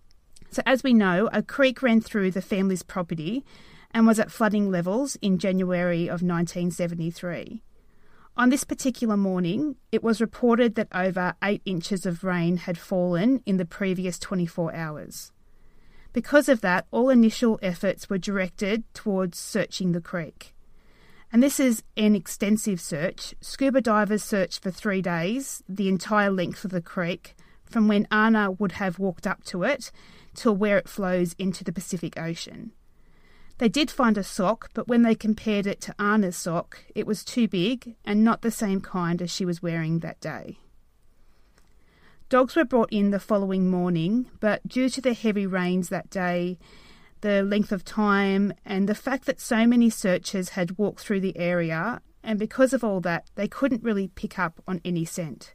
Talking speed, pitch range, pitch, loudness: 175 wpm, 180-225 Hz, 200 Hz, -25 LUFS